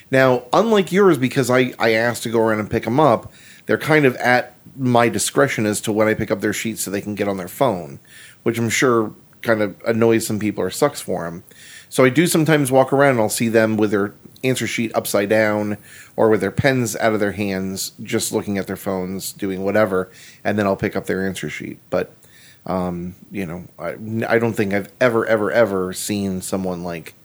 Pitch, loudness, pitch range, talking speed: 110 Hz, -19 LUFS, 100-120 Hz, 220 wpm